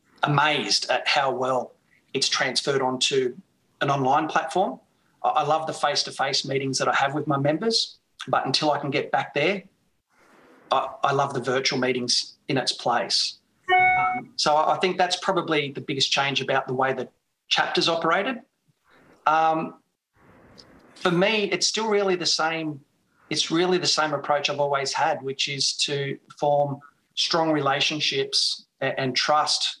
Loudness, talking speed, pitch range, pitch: -23 LUFS, 150 wpm, 140-180 Hz, 150 Hz